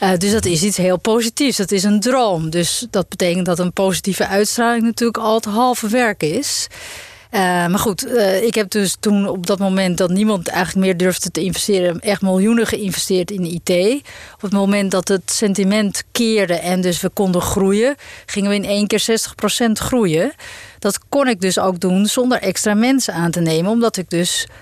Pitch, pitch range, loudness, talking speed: 200 Hz, 185-225 Hz, -17 LUFS, 195 wpm